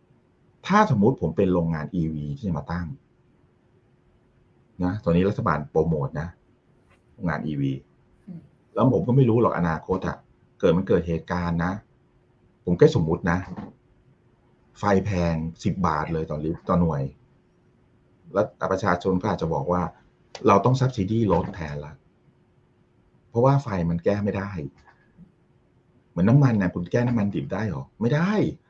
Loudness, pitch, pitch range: -24 LUFS, 90 Hz, 80-105 Hz